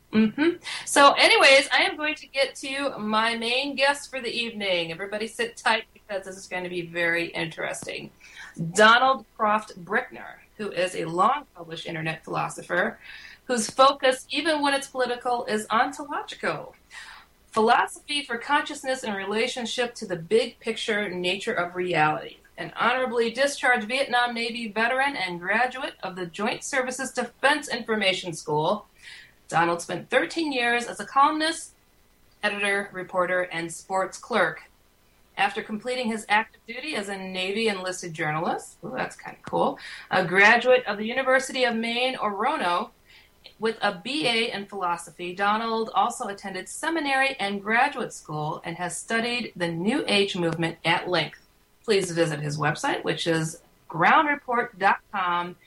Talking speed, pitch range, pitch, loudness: 145 wpm, 185-260 Hz, 225 Hz, -24 LUFS